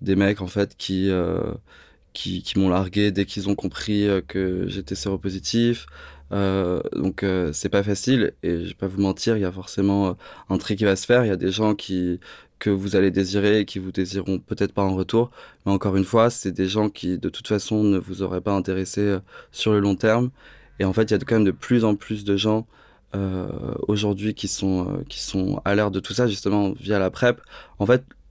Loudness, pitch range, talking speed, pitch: -23 LUFS, 95-105 Hz, 230 wpm, 100 Hz